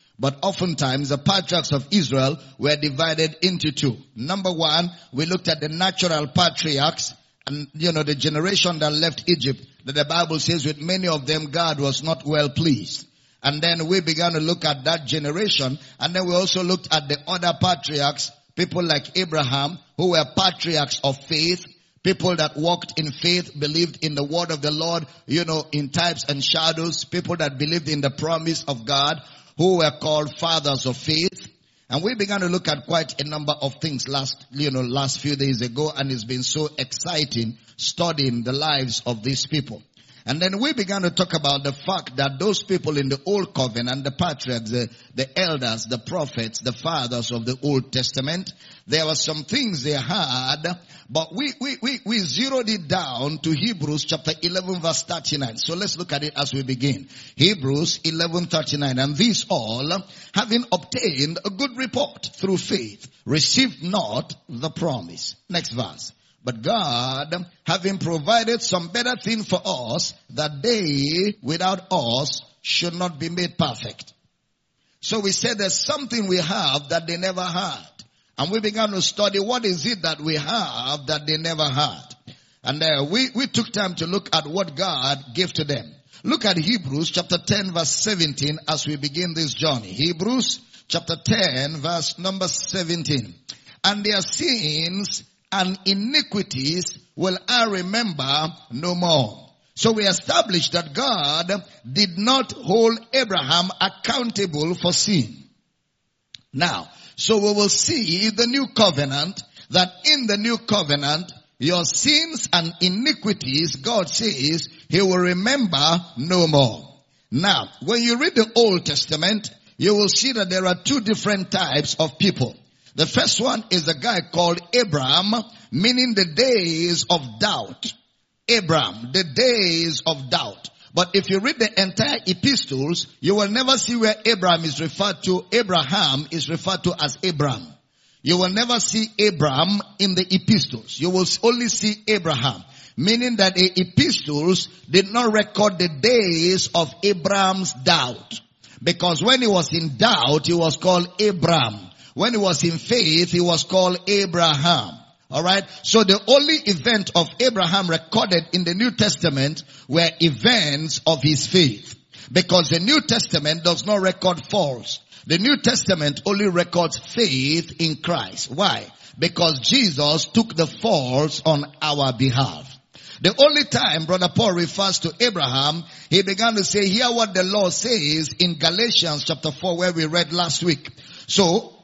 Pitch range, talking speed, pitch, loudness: 145-195 Hz, 165 wpm, 170 Hz, -20 LUFS